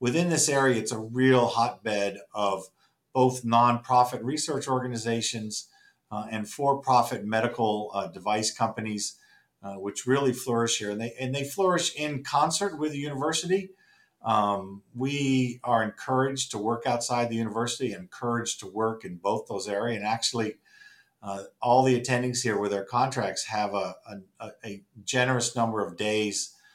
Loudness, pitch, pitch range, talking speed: -27 LUFS, 120 Hz, 105-130 Hz, 155 wpm